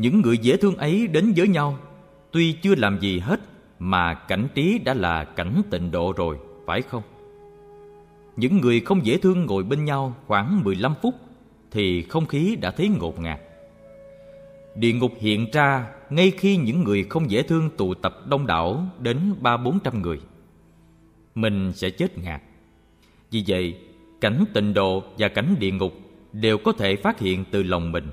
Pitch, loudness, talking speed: 115 Hz, -22 LUFS, 175 wpm